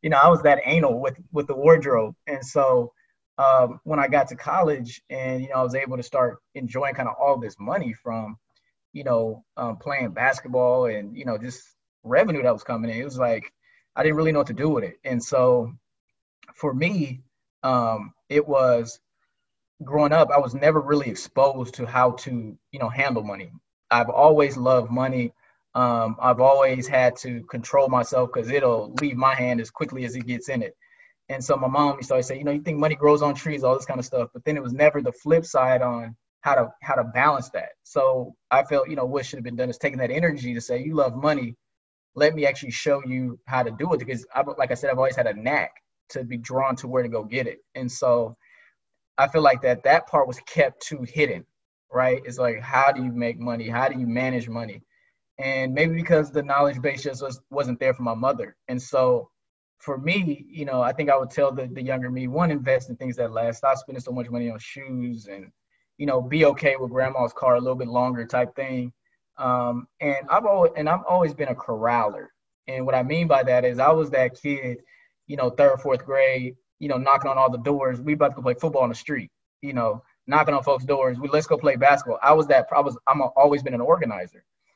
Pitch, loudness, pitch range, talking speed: 130 Hz, -23 LUFS, 125-145 Hz, 235 wpm